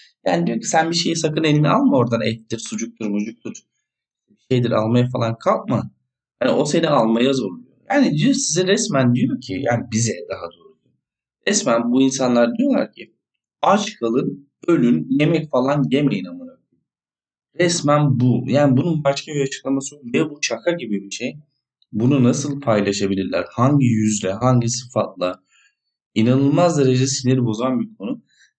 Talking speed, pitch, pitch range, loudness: 150 wpm, 130 Hz, 115-155 Hz, -19 LUFS